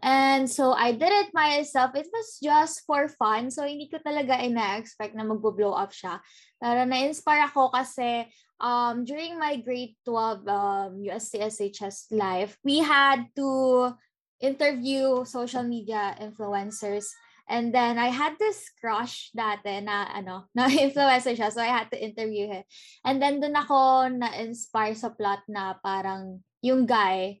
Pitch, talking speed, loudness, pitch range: 240 Hz, 150 wpm, -26 LUFS, 210-270 Hz